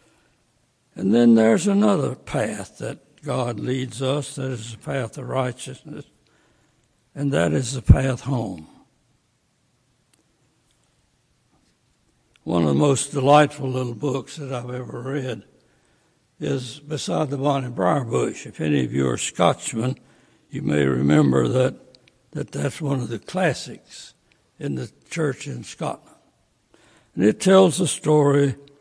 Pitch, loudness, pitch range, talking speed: 135 Hz, -22 LUFS, 125-145 Hz, 135 wpm